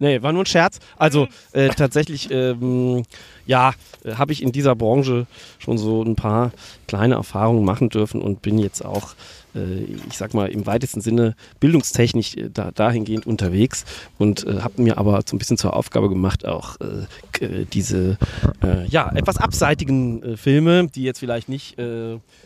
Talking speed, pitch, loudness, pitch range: 175 wpm, 115 Hz, -20 LUFS, 100-130 Hz